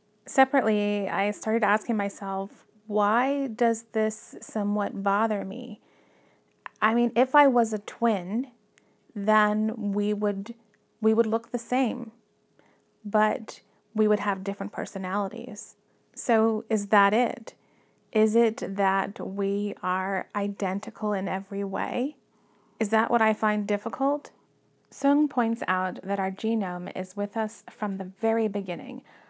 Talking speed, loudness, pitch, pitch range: 130 wpm, -26 LUFS, 215 Hz, 200-230 Hz